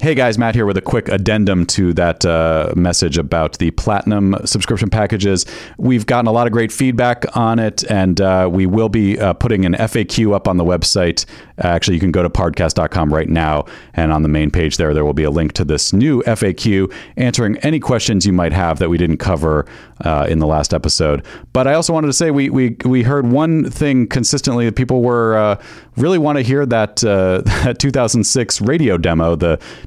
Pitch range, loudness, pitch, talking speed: 85-120 Hz, -15 LUFS, 100 Hz, 210 wpm